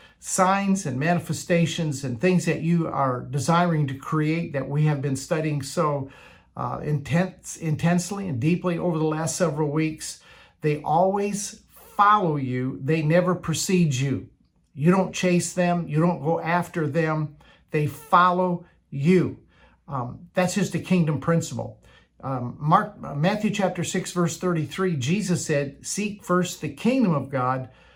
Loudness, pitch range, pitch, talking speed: -24 LUFS, 145-180 Hz, 165 Hz, 145 wpm